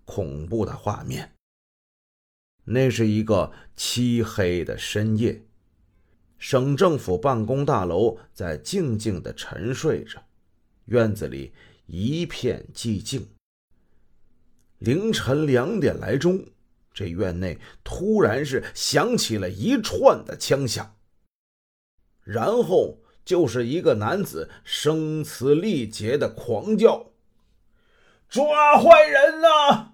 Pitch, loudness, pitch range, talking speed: 110 Hz, -22 LUFS, 95-140 Hz, 150 characters per minute